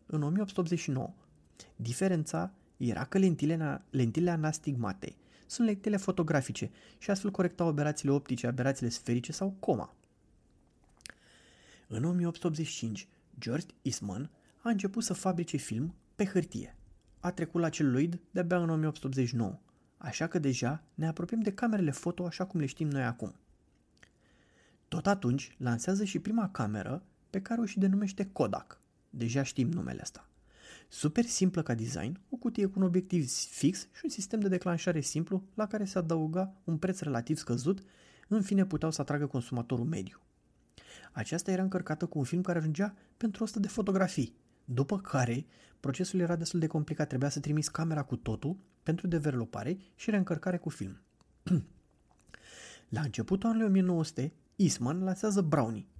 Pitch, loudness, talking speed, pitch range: 160 Hz, -33 LUFS, 150 wpm, 135-190 Hz